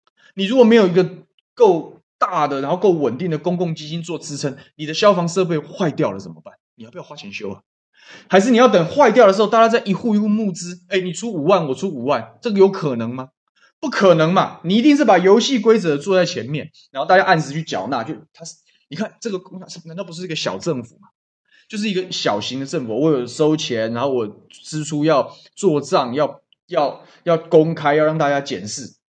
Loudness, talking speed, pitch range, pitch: -17 LUFS, 315 characters per minute, 155-200 Hz, 175 Hz